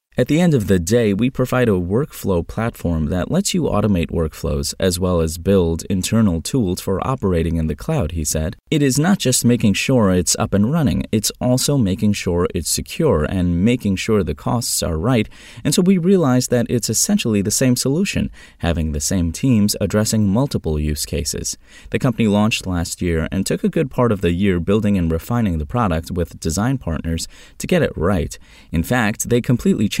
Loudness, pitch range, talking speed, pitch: -18 LUFS, 85-125 Hz, 200 wpm, 100 Hz